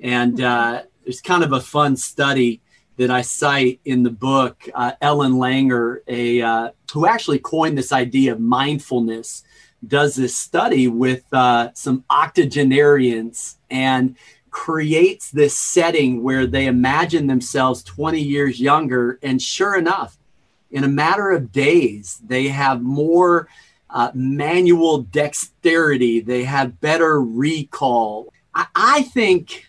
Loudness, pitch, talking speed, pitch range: -17 LUFS, 135 Hz, 130 wpm, 125-150 Hz